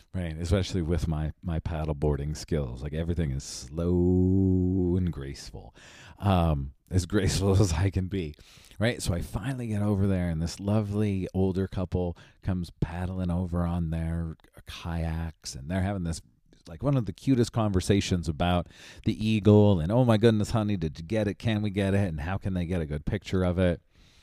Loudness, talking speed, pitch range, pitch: -28 LUFS, 185 wpm, 85-100 Hz, 90 Hz